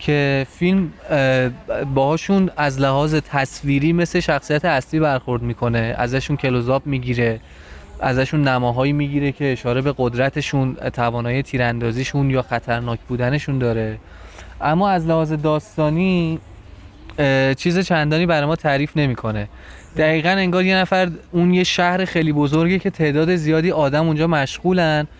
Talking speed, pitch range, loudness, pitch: 125 wpm, 125-160 Hz, -19 LUFS, 145 Hz